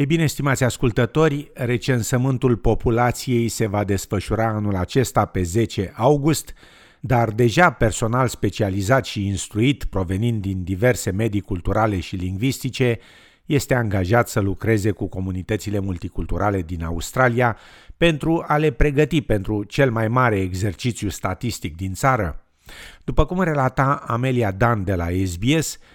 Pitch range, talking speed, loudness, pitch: 100-130 Hz, 130 wpm, -21 LUFS, 115 Hz